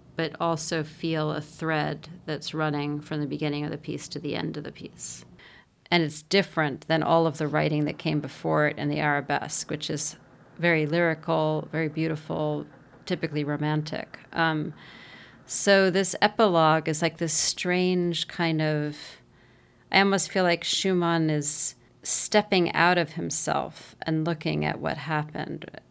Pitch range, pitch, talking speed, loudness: 150-170 Hz, 160 Hz, 155 wpm, -26 LUFS